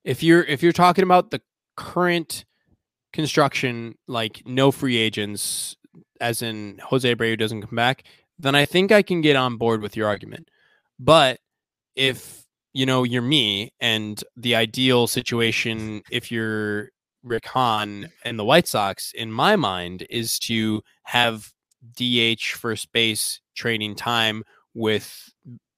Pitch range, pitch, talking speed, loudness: 110-130 Hz, 120 Hz, 140 wpm, -21 LUFS